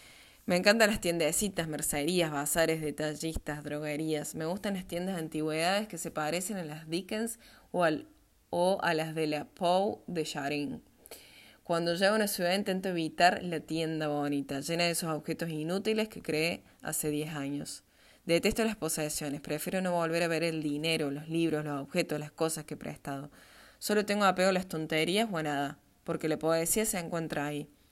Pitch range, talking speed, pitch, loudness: 150-180 Hz, 180 wpm, 160 Hz, -31 LUFS